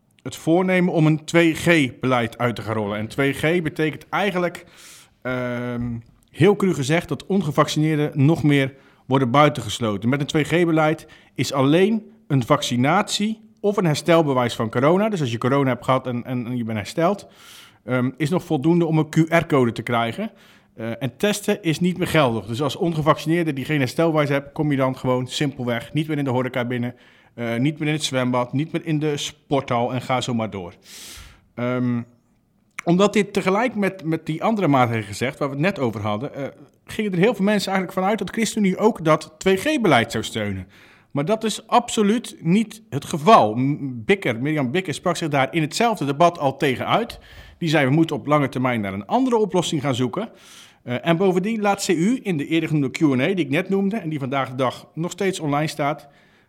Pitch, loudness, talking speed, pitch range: 150 Hz, -21 LUFS, 195 wpm, 125-175 Hz